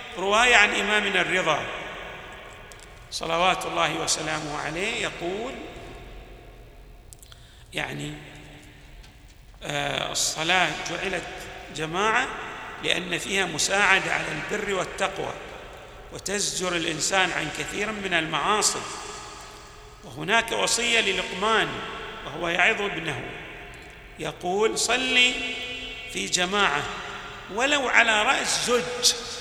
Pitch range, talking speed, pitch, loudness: 180-245 Hz, 80 wpm, 205 Hz, -24 LUFS